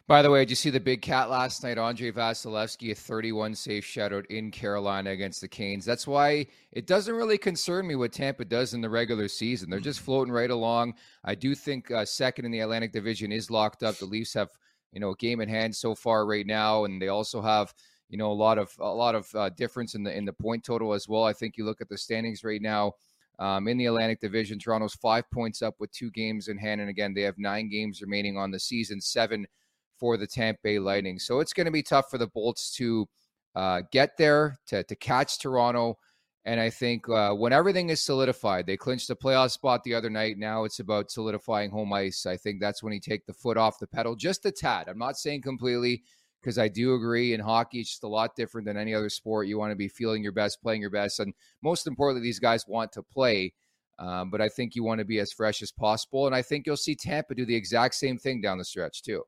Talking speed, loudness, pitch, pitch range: 245 wpm, -28 LUFS, 115 Hz, 105-125 Hz